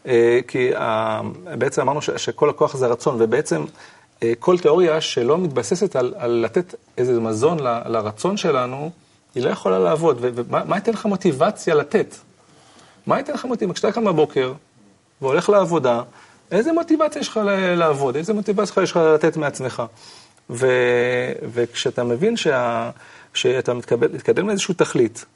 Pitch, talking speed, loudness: 155 Hz, 135 wpm, -20 LUFS